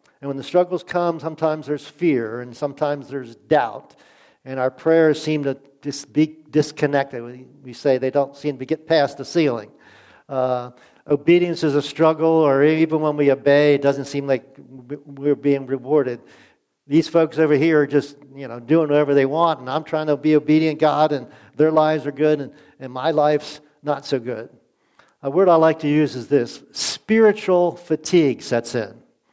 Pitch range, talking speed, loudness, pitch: 135-155 Hz, 185 wpm, -19 LUFS, 145 Hz